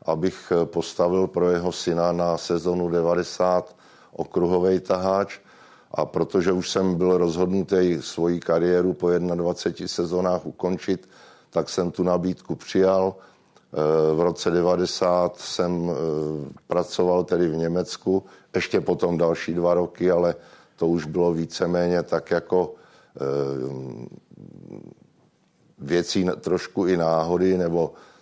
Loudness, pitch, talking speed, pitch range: -23 LUFS, 90 Hz, 110 wpm, 85-90 Hz